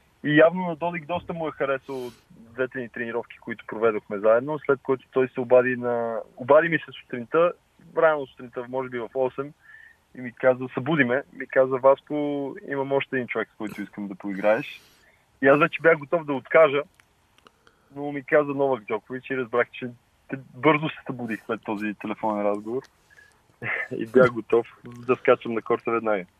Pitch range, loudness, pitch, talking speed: 115-145 Hz, -24 LUFS, 130 Hz, 175 wpm